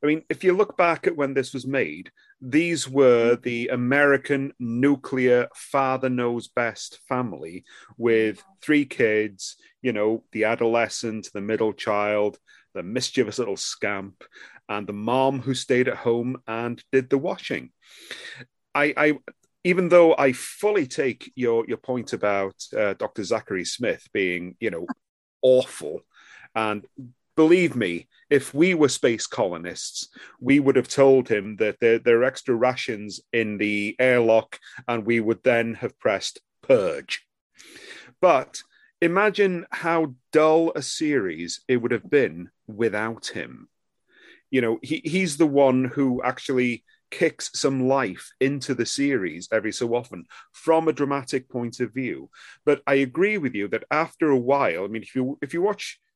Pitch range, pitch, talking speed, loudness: 115-145 Hz, 130 Hz, 155 wpm, -23 LUFS